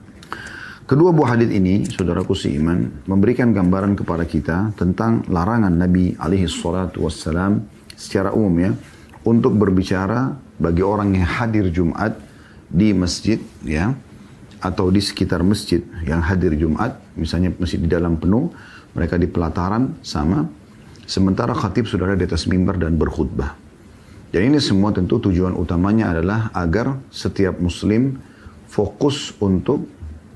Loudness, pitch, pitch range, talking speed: -19 LUFS, 95 Hz, 85-105 Hz, 130 wpm